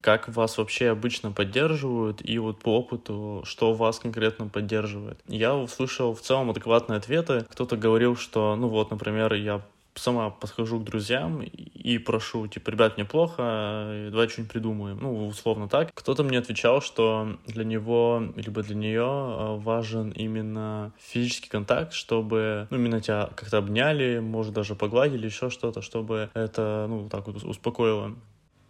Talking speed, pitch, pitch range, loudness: 150 wpm, 110 Hz, 105-120 Hz, -27 LUFS